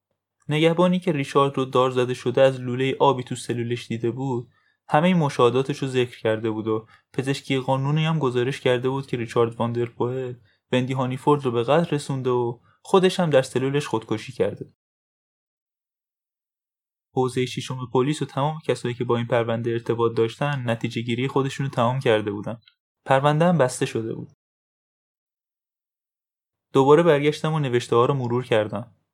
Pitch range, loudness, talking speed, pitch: 120-140 Hz, -23 LUFS, 155 wpm, 130 Hz